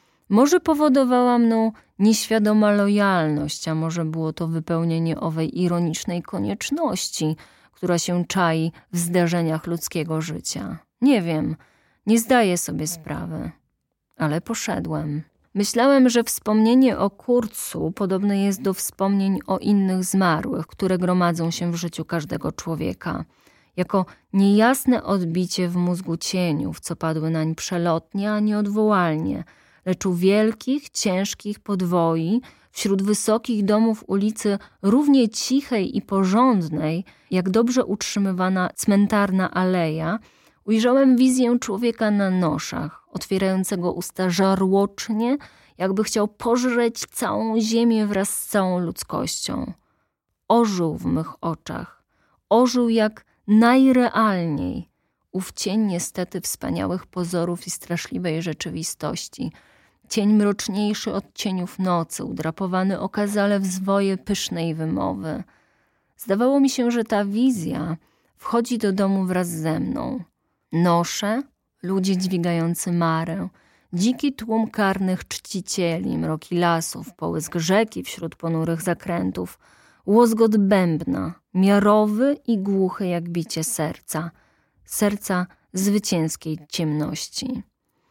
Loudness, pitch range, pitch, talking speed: -22 LUFS, 170-215 Hz, 190 Hz, 110 wpm